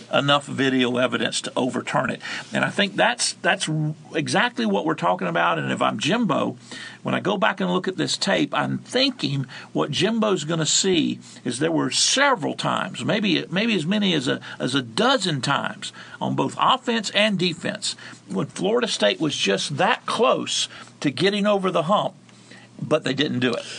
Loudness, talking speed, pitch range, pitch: -22 LUFS, 185 wpm, 145-210 Hz, 180 Hz